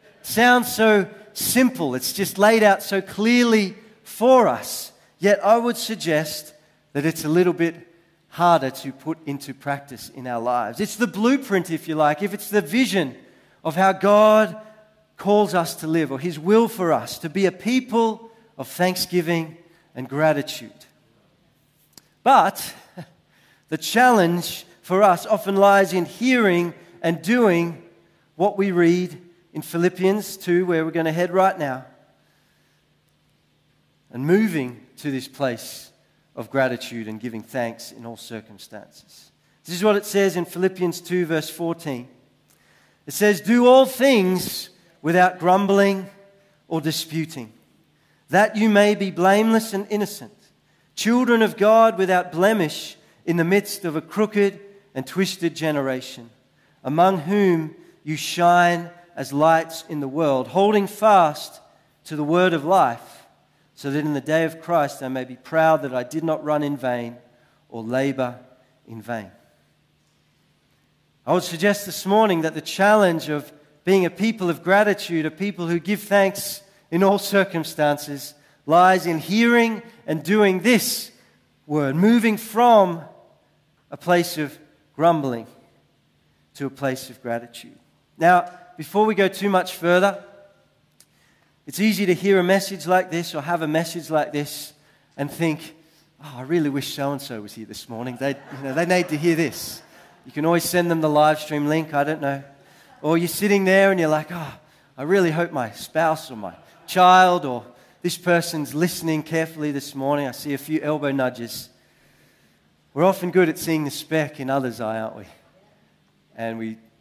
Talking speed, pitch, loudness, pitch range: 160 wpm, 170 Hz, -20 LUFS, 145-195 Hz